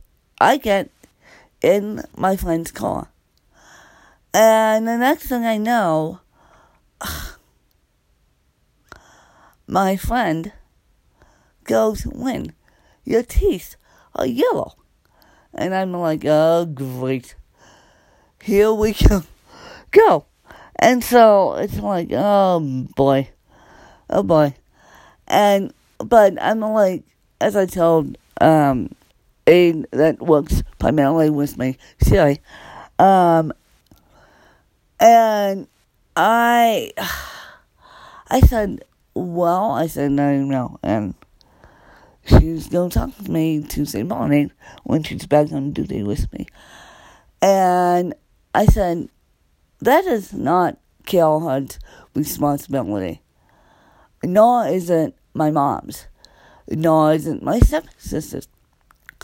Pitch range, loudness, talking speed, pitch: 150-215 Hz, -18 LUFS, 100 wpm, 175 Hz